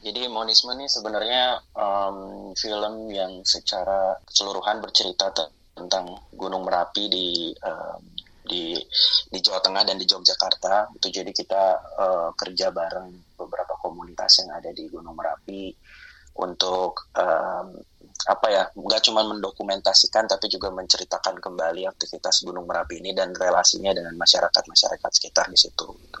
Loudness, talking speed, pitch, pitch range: -22 LUFS, 135 wpm, 95 Hz, 95-110 Hz